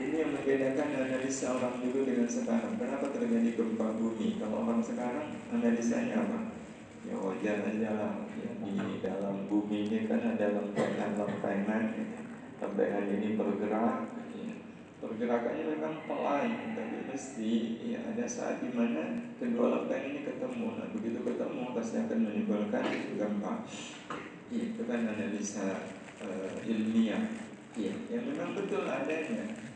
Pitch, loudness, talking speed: 235 Hz, -34 LUFS, 130 wpm